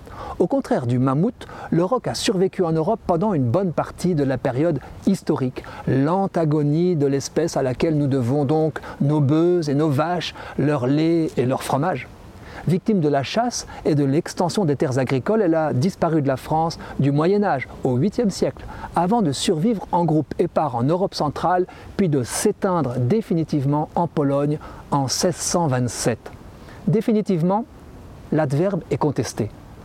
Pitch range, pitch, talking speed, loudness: 140-185 Hz, 155 Hz, 160 wpm, -21 LUFS